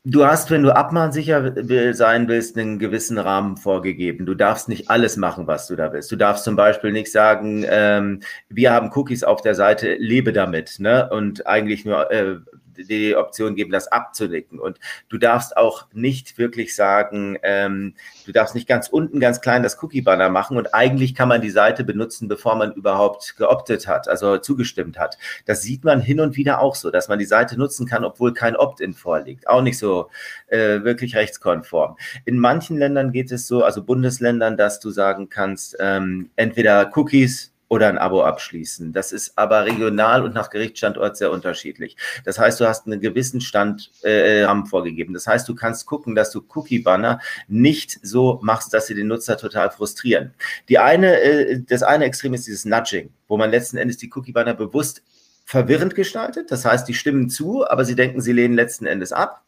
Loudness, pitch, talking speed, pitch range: -19 LUFS, 115 Hz, 190 wpm, 105-125 Hz